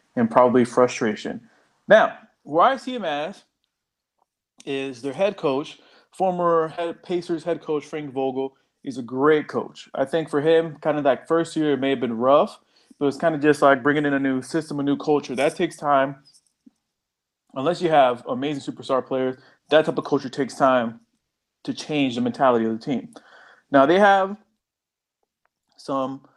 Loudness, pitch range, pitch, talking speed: -22 LUFS, 135-165 Hz, 145 Hz, 180 wpm